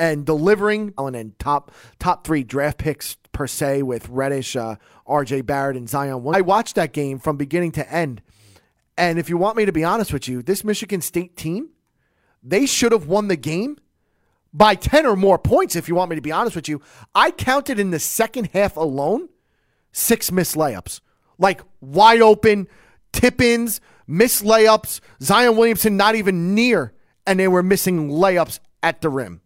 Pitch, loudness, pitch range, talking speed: 175 Hz, -19 LUFS, 145-210 Hz, 180 wpm